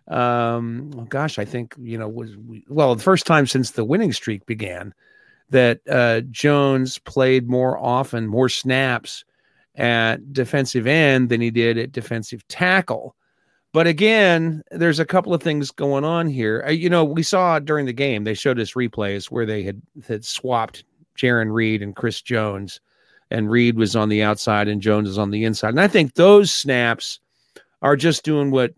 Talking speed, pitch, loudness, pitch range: 180 wpm, 125 Hz, -19 LUFS, 115-150 Hz